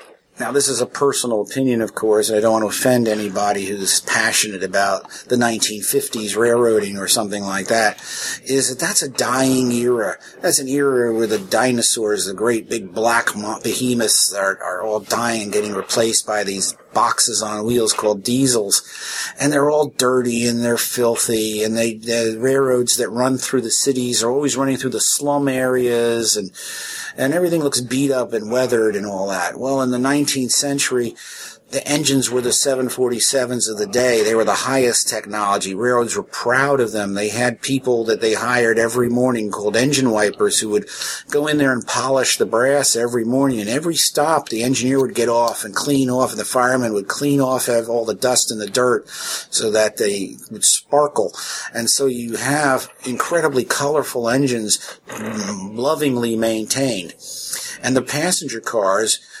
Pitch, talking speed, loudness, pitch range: 120 Hz, 180 wpm, -18 LUFS, 110-130 Hz